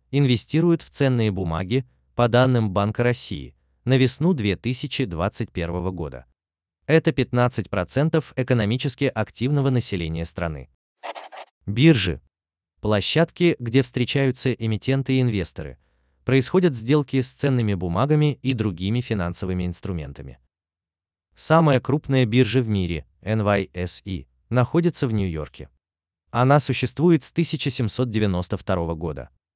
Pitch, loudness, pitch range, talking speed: 110 Hz, -22 LUFS, 85-130 Hz, 95 wpm